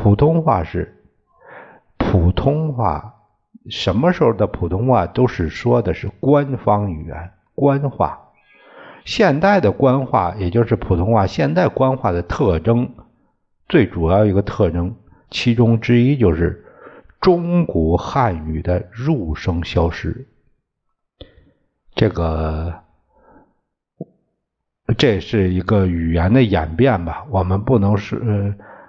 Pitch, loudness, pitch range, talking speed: 100 Hz, -17 LUFS, 85-120 Hz, 175 characters per minute